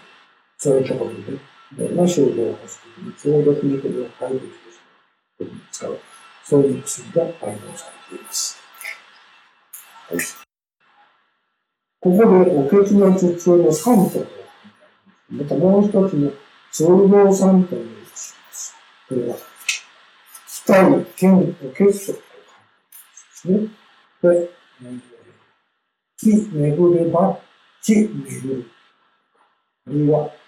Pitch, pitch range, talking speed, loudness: 180 Hz, 150-200 Hz, 210 characters per minute, -18 LUFS